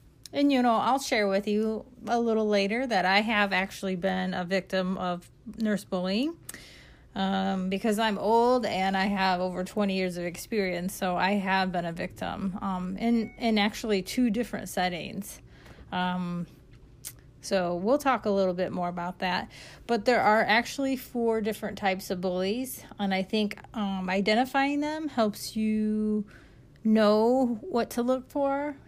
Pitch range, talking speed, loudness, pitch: 185-230 Hz, 160 wpm, -28 LUFS, 205 Hz